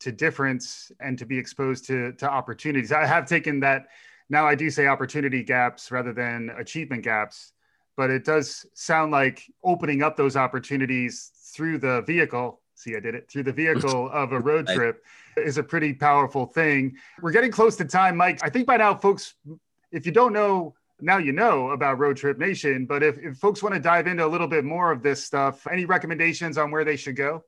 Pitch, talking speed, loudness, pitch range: 150 Hz, 205 wpm, -23 LUFS, 135-165 Hz